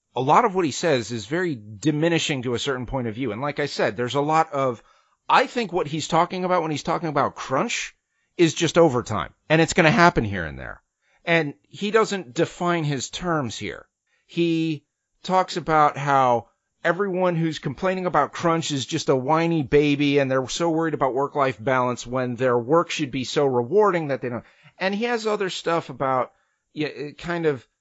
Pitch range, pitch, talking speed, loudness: 130-170 Hz, 150 Hz, 205 wpm, -22 LUFS